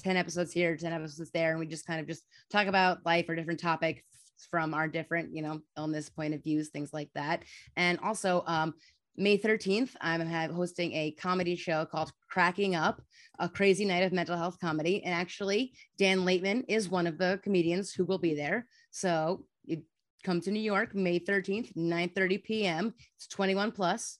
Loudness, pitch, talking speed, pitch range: -31 LUFS, 175 Hz, 190 wpm, 165-195 Hz